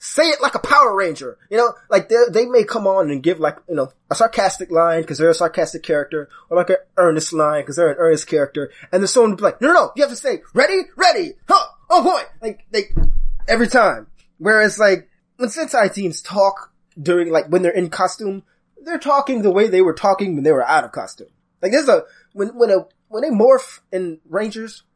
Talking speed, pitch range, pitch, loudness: 225 wpm, 175-280 Hz, 200 Hz, -17 LUFS